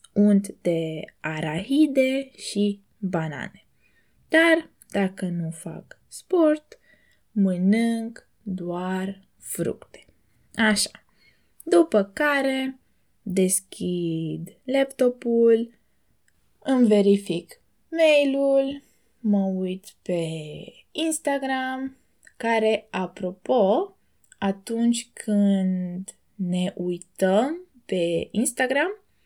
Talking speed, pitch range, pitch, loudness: 70 wpm, 185-265 Hz, 205 Hz, -24 LUFS